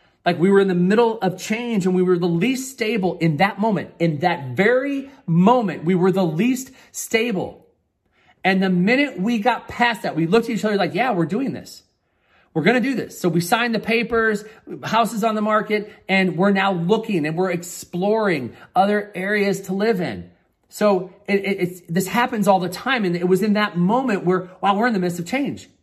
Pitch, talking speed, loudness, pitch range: 195 Hz, 215 wpm, -20 LUFS, 180-225 Hz